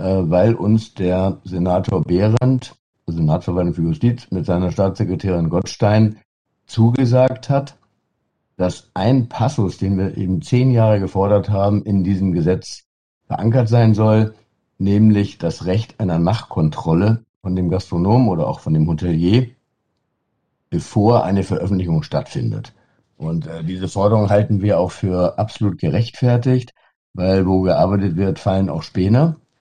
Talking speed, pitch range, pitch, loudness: 130 wpm, 90-115 Hz, 100 Hz, -18 LUFS